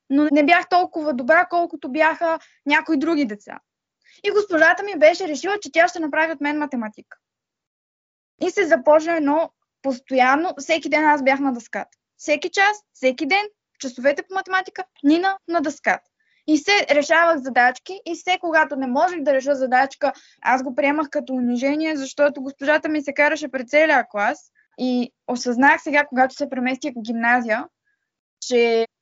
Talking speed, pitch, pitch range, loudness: 160 wpm, 300 Hz, 270-335 Hz, -20 LUFS